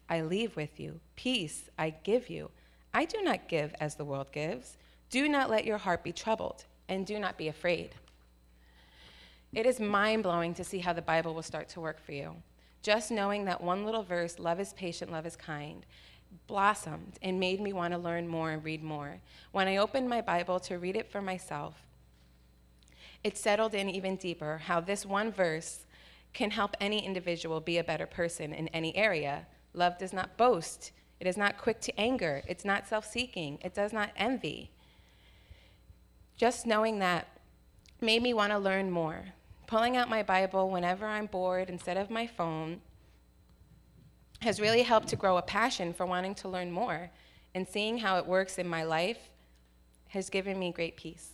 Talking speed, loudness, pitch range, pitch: 185 wpm, -33 LUFS, 160-210 Hz, 180 Hz